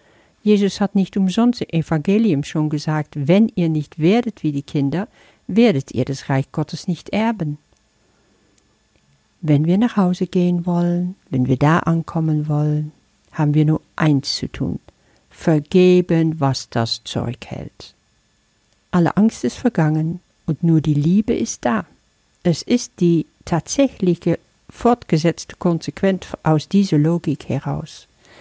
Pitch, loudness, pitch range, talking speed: 165 Hz, -19 LUFS, 150-185 Hz, 135 wpm